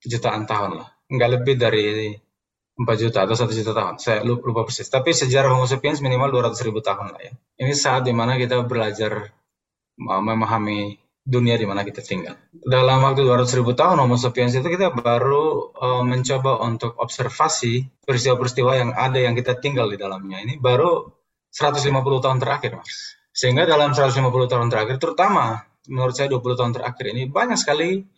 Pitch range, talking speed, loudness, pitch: 115-135 Hz, 160 wpm, -20 LUFS, 125 Hz